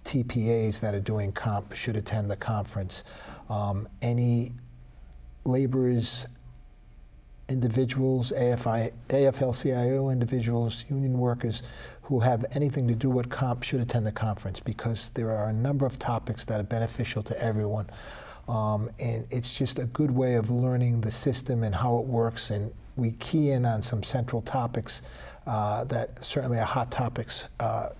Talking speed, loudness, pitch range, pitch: 150 wpm, -28 LUFS, 110-125 Hz, 120 Hz